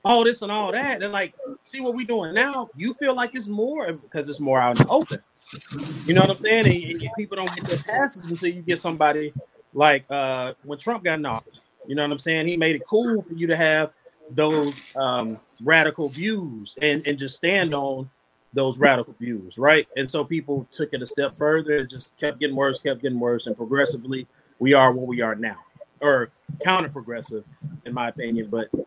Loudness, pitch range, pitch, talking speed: -23 LUFS, 135-180 Hz, 150 Hz, 215 wpm